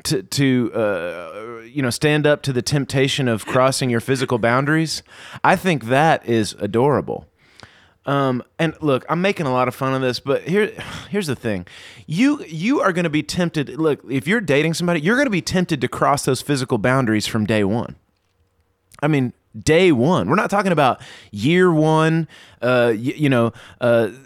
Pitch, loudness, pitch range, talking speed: 135 Hz, -19 LUFS, 115-155 Hz, 190 wpm